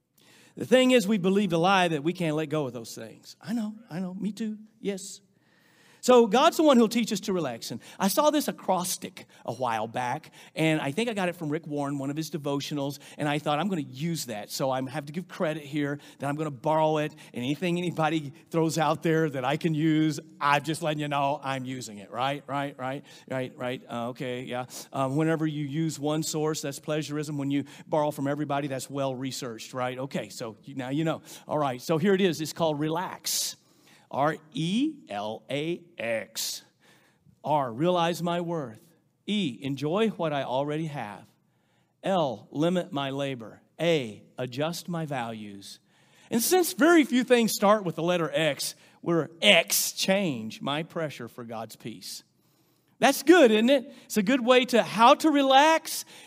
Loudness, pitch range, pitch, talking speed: -27 LUFS, 140-190 Hz, 155 Hz, 195 wpm